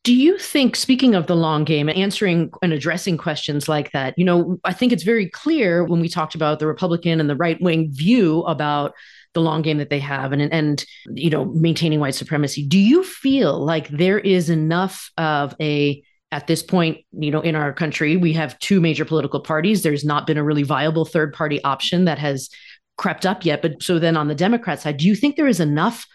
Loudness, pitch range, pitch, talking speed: -19 LUFS, 150-185 Hz, 160 Hz, 225 wpm